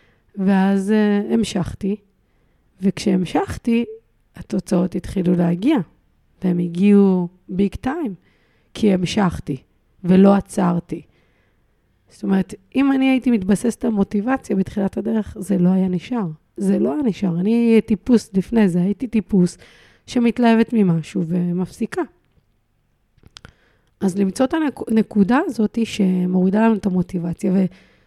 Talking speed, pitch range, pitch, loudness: 110 wpm, 180-220 Hz, 195 Hz, -19 LUFS